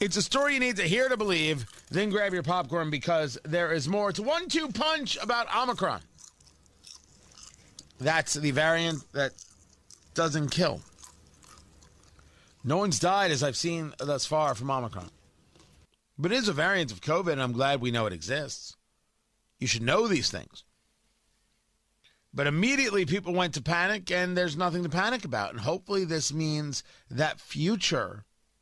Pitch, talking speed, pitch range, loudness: 155 Hz, 160 wpm, 120-190 Hz, -28 LUFS